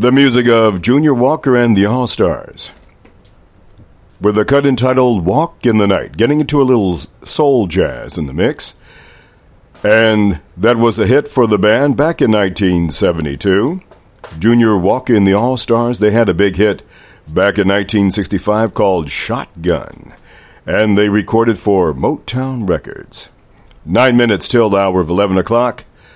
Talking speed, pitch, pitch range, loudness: 155 wpm, 110 Hz, 100-125 Hz, -13 LUFS